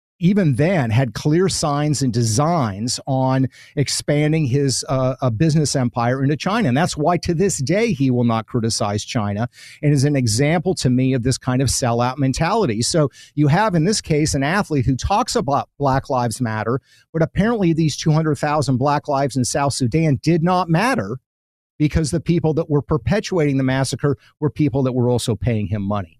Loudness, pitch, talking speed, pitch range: -19 LUFS, 140 Hz, 190 wpm, 125-155 Hz